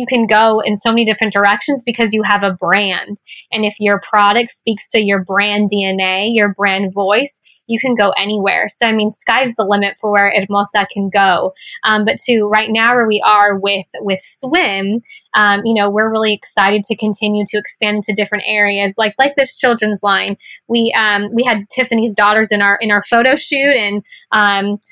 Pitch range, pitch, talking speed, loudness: 200-230 Hz, 210 Hz, 200 wpm, -13 LUFS